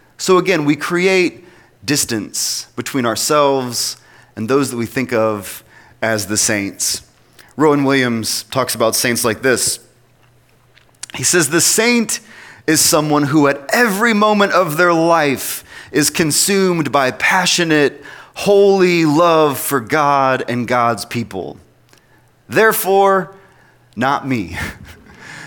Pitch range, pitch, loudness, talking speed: 120-175 Hz, 140 Hz, -15 LUFS, 120 wpm